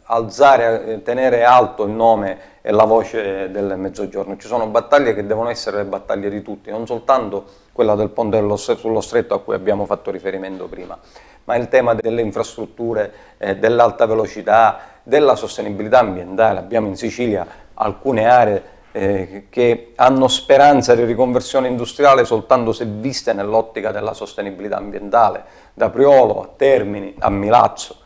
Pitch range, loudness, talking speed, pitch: 100-120 Hz, -16 LUFS, 145 wpm, 115 Hz